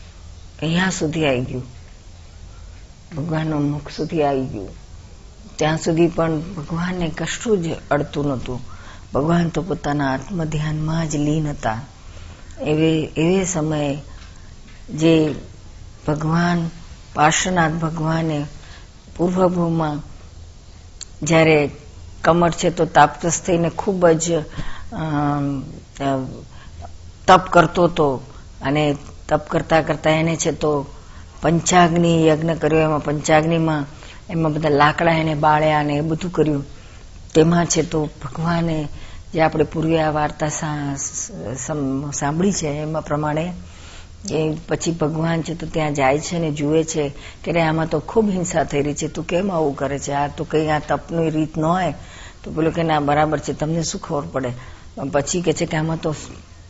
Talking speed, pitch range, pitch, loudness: 130 wpm, 135-160 Hz, 150 Hz, -20 LUFS